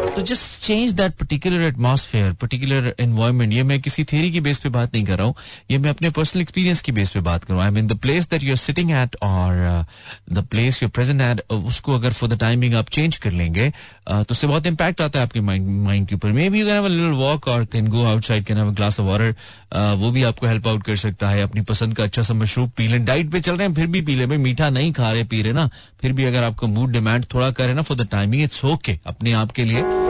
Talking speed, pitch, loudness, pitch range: 205 wpm, 120 Hz, -20 LUFS, 110-145 Hz